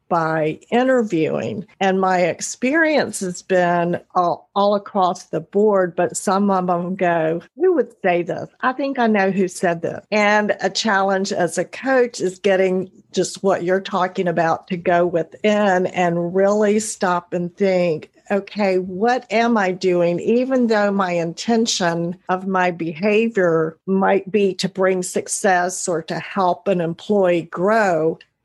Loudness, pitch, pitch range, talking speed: -19 LUFS, 185 Hz, 175-205 Hz, 150 wpm